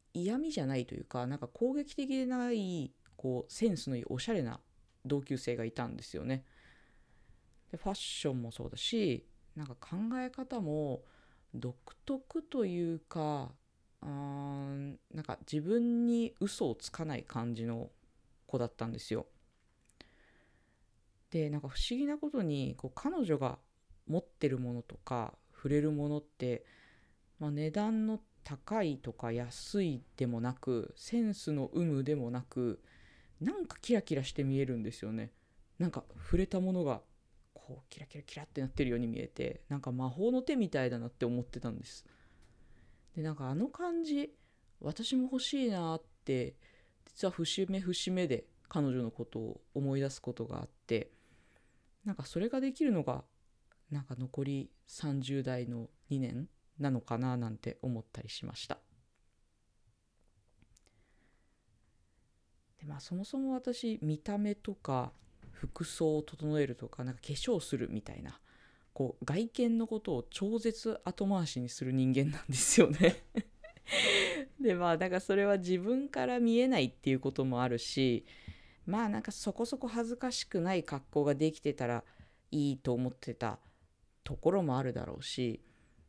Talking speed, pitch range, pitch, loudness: 290 characters per minute, 125-195 Hz, 145 Hz, -36 LUFS